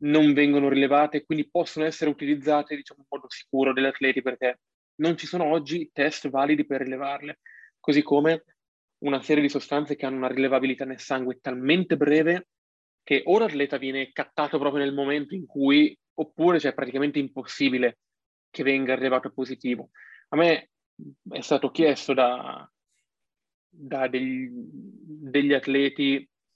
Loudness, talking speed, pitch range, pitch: -25 LUFS, 150 wpm, 135-150 Hz, 140 Hz